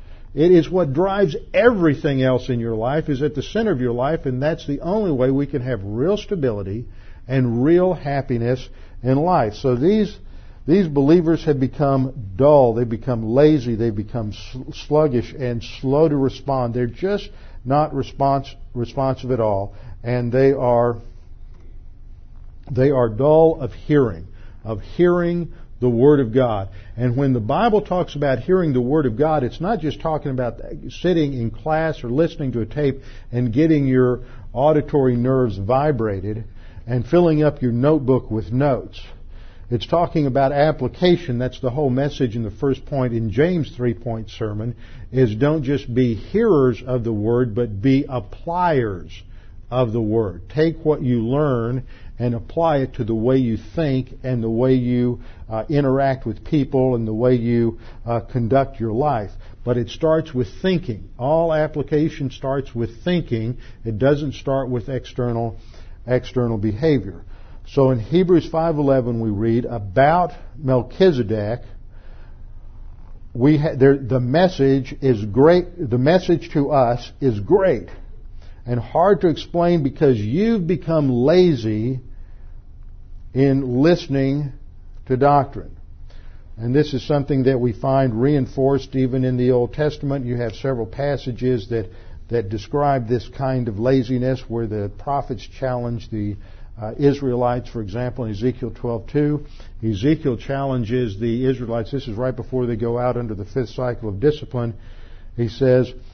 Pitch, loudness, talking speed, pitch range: 125 Hz, -20 LUFS, 155 wpm, 115-145 Hz